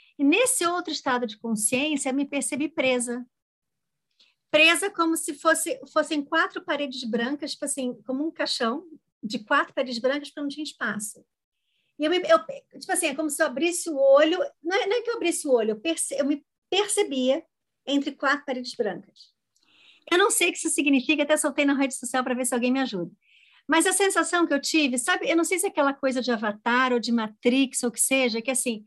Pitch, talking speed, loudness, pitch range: 285 Hz, 215 wpm, -24 LUFS, 255-325 Hz